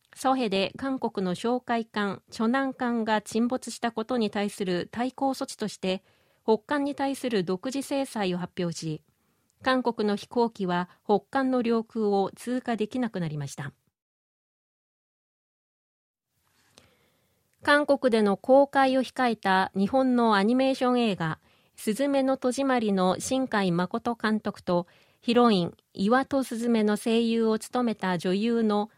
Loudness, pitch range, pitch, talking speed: -27 LUFS, 195-255 Hz, 230 Hz, 255 characters per minute